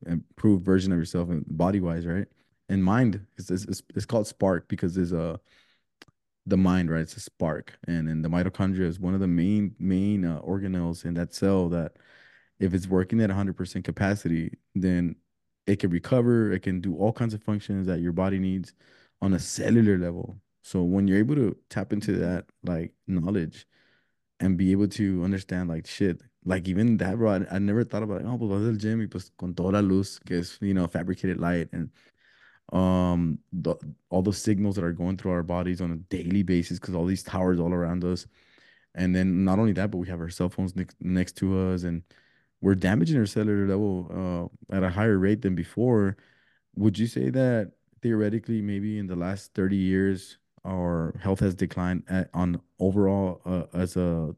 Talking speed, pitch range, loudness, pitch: 195 wpm, 90-100 Hz, -27 LUFS, 95 Hz